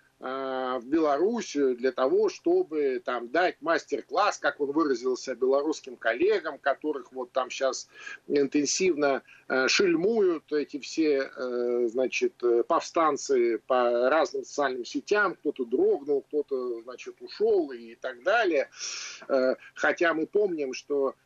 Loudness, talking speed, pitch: -27 LUFS, 110 wpm, 165 Hz